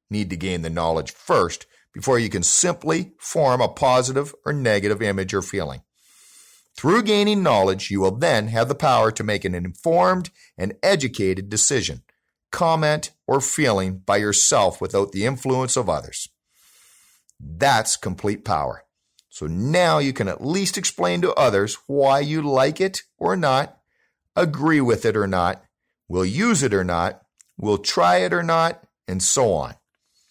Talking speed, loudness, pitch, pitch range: 160 wpm, -20 LUFS, 110 Hz, 95-150 Hz